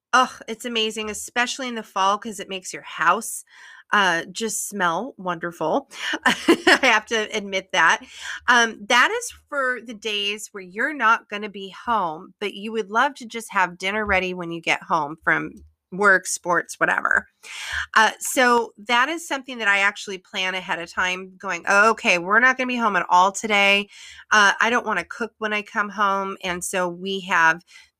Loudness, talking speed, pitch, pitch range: -21 LUFS, 190 wpm, 205 Hz, 190-230 Hz